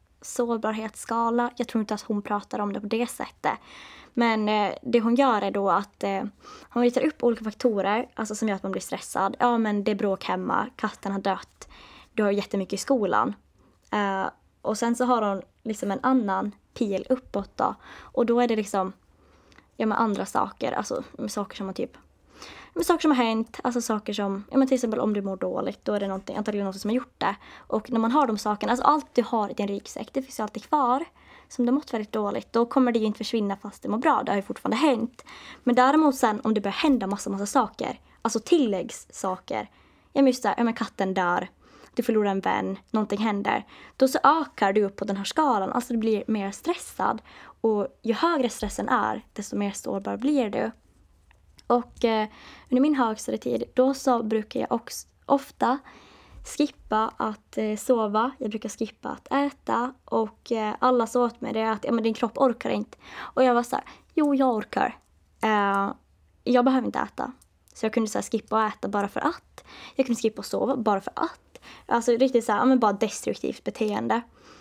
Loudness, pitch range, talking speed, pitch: -26 LUFS, 205-250 Hz, 210 wpm, 225 Hz